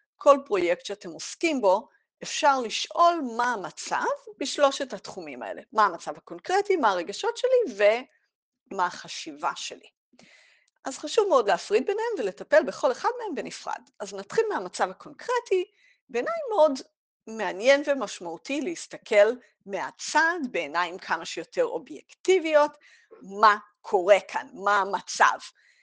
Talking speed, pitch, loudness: 115 wpm, 285 Hz, -25 LUFS